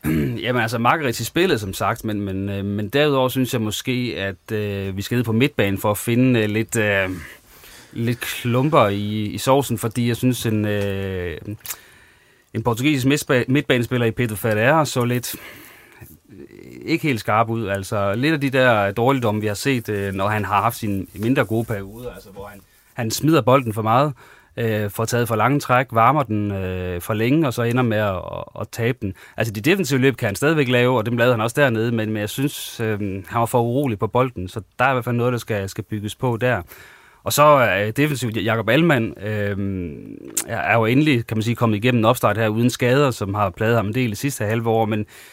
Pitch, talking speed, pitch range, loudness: 115 Hz, 210 wpm, 105-125 Hz, -20 LUFS